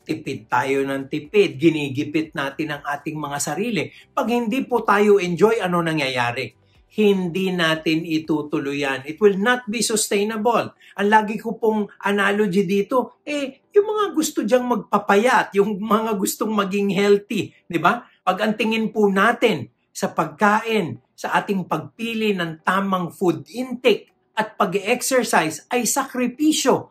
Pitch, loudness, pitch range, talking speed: 205 Hz, -21 LUFS, 160-230 Hz, 140 wpm